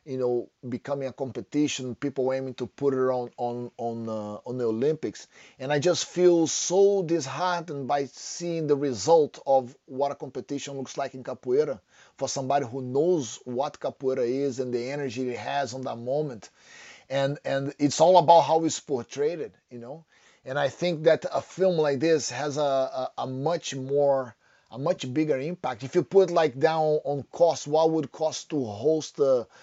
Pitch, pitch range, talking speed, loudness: 140 Hz, 130-160 Hz, 190 wpm, -26 LUFS